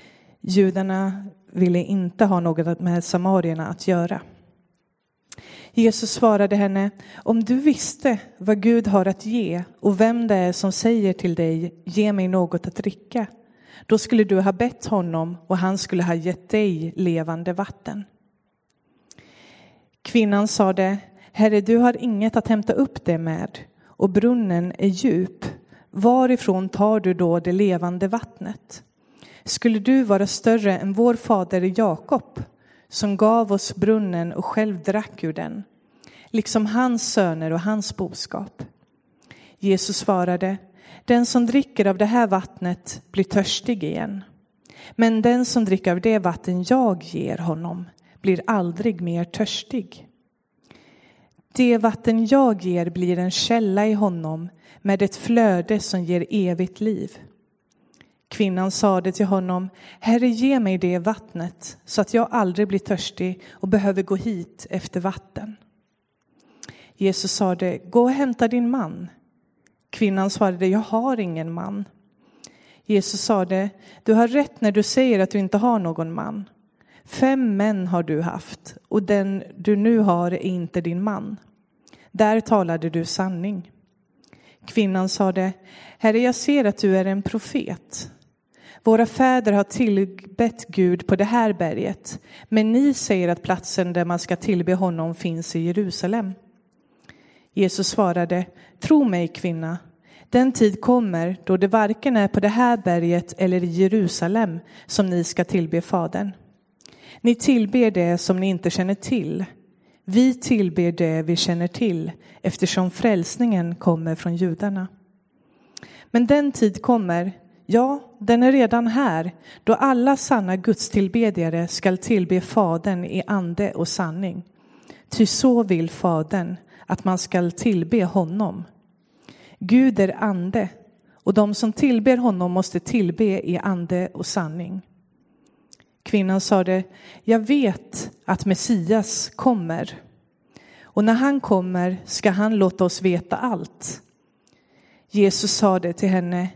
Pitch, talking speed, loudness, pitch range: 200 Hz, 140 wpm, -21 LUFS, 180-225 Hz